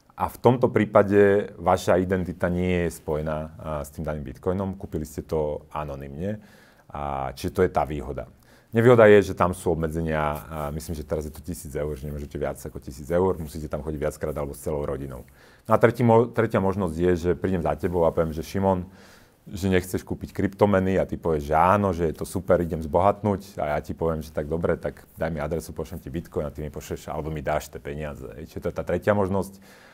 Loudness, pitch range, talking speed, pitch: -25 LUFS, 75-95 Hz, 225 wpm, 85 Hz